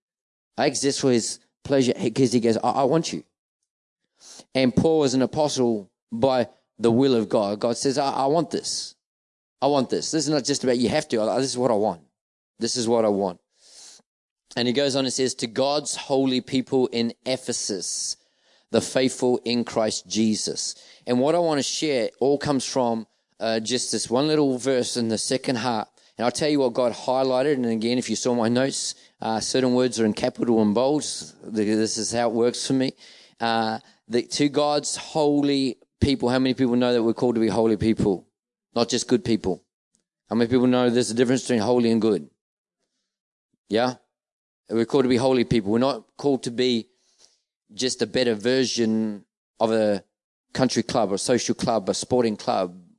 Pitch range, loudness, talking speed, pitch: 115-130 Hz, -23 LUFS, 195 wpm, 125 Hz